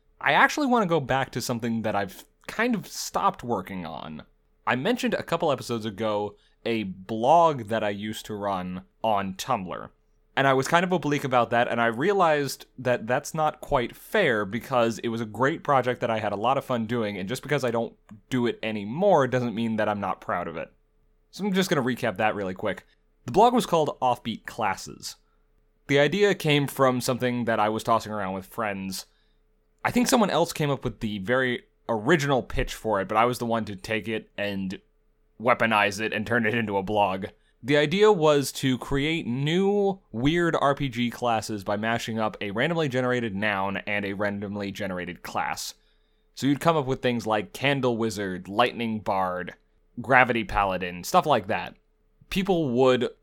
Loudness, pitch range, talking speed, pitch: -25 LUFS, 105-140 Hz, 195 wpm, 120 Hz